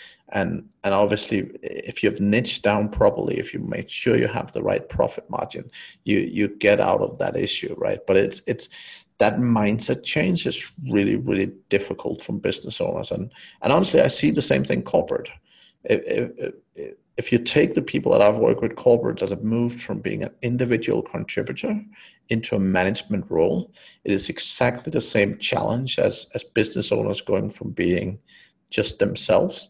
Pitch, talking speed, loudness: 180 Hz, 175 wpm, -23 LUFS